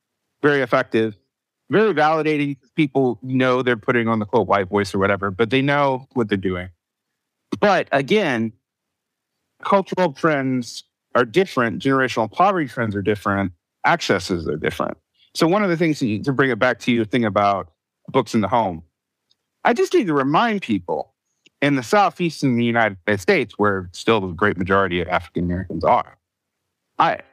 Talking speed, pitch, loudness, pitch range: 170 wpm, 120 Hz, -20 LUFS, 100-140 Hz